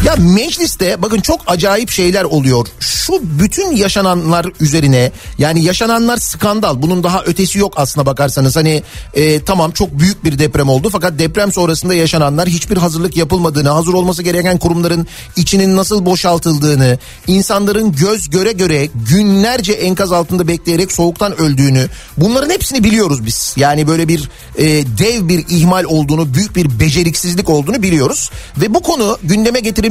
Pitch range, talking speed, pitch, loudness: 155-195 Hz, 150 wpm, 175 Hz, -12 LUFS